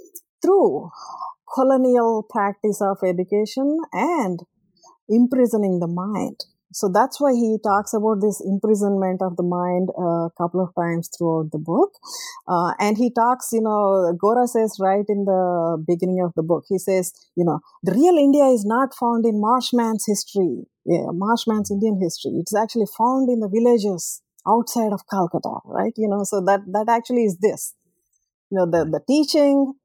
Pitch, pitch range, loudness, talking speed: 210 Hz, 185-240 Hz, -20 LUFS, 165 wpm